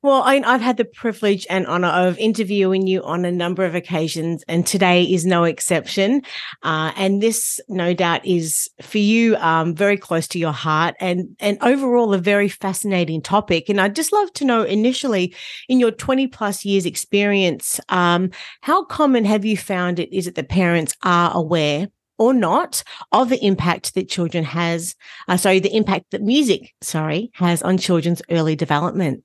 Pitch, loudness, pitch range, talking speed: 185 Hz, -18 LUFS, 170-215 Hz, 180 wpm